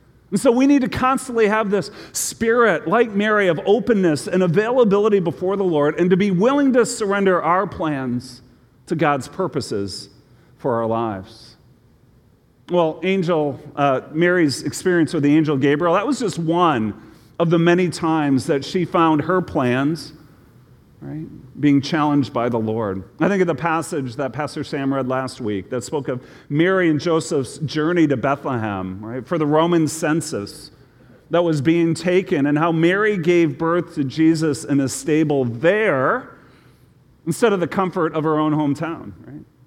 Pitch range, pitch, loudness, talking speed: 135-180 Hz, 155 Hz, -19 LUFS, 165 wpm